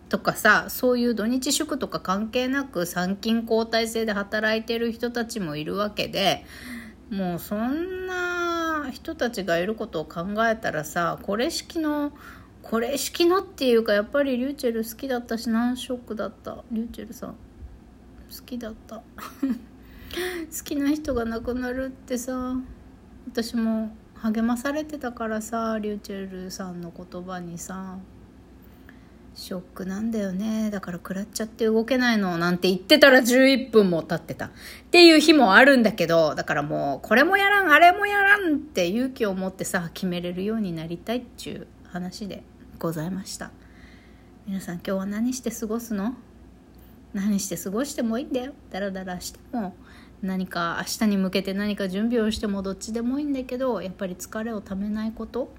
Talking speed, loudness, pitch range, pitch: 335 characters per minute, -24 LUFS, 190-255 Hz, 225 Hz